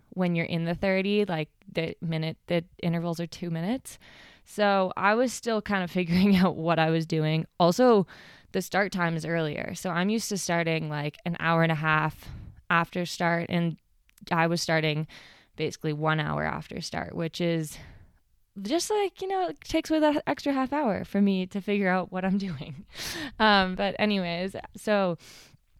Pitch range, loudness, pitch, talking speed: 160-200 Hz, -27 LUFS, 175 Hz, 180 wpm